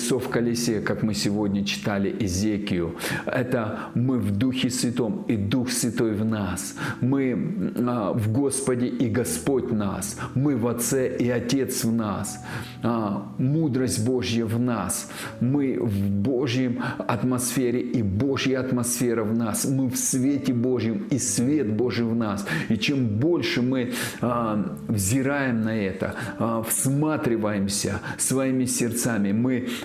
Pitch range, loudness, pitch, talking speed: 110-130 Hz, -24 LUFS, 120 Hz, 125 wpm